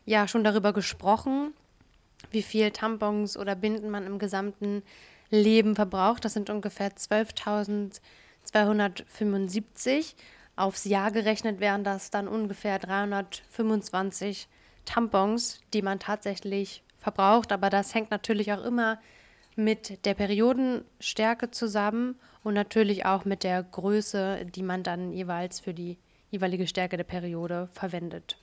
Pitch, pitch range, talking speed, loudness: 205 Hz, 195-220 Hz, 120 wpm, -28 LUFS